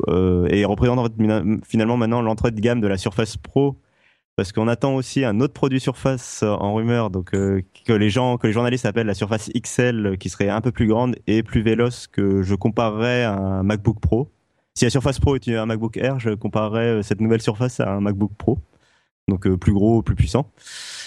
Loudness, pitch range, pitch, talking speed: -21 LUFS, 100-120 Hz, 110 Hz, 215 wpm